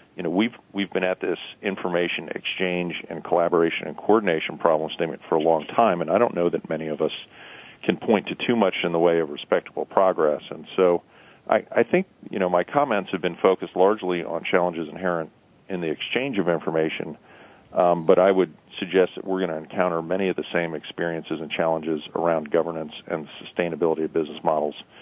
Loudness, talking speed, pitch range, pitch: -24 LUFS, 195 wpm, 80-90 Hz, 85 Hz